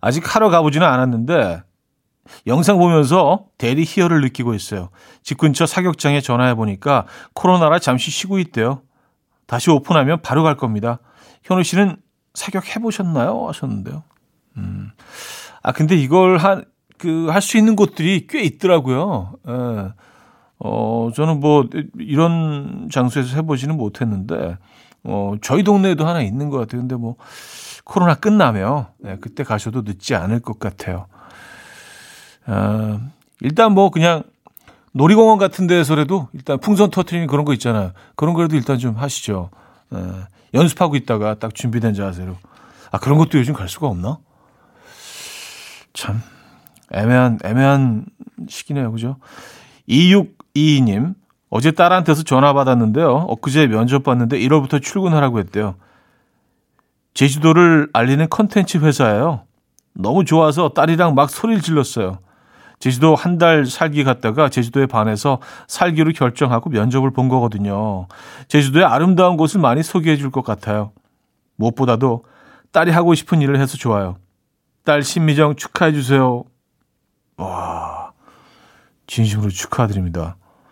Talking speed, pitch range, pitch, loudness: 290 characters per minute, 115-170 Hz, 140 Hz, -16 LUFS